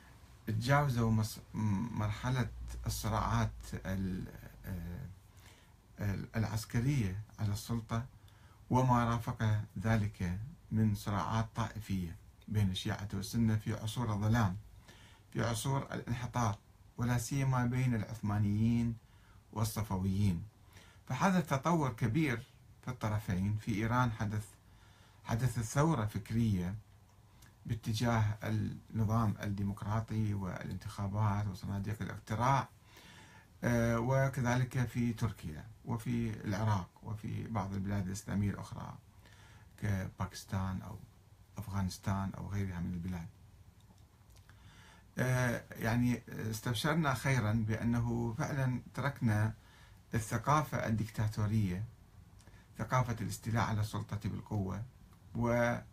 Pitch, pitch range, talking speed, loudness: 110 Hz, 100-120 Hz, 80 wpm, -36 LUFS